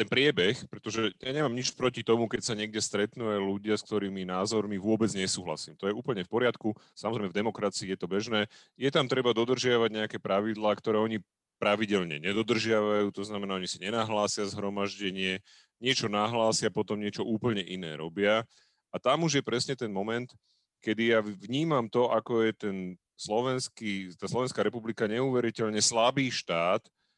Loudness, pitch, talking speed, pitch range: -30 LUFS, 110 Hz, 165 wpm, 100-115 Hz